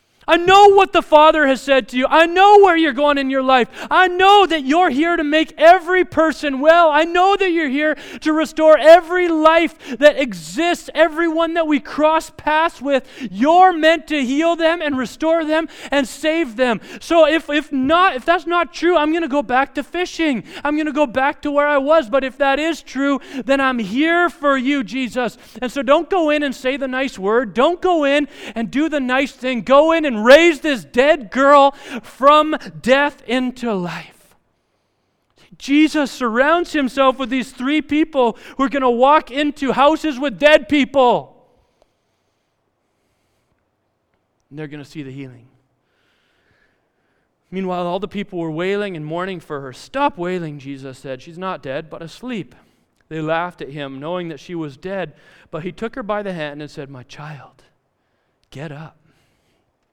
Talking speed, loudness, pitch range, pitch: 185 wpm, -16 LUFS, 225-315 Hz, 280 Hz